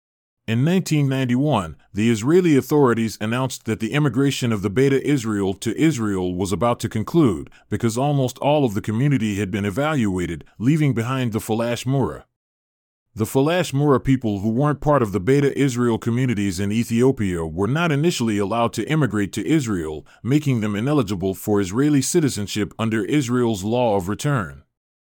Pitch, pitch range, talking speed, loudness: 115 Hz, 105-140 Hz, 160 wpm, -21 LUFS